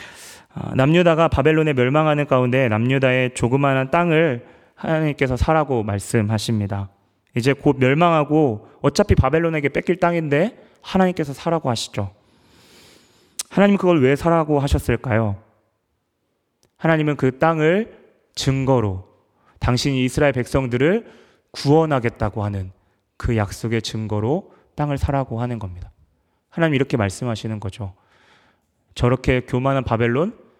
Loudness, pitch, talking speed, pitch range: -19 LUFS, 130 Hz, 300 characters per minute, 110-155 Hz